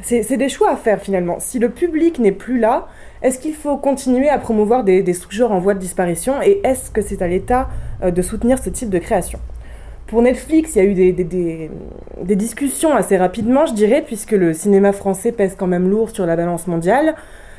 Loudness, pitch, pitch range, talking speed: -16 LUFS, 210 Hz, 185-255 Hz, 220 wpm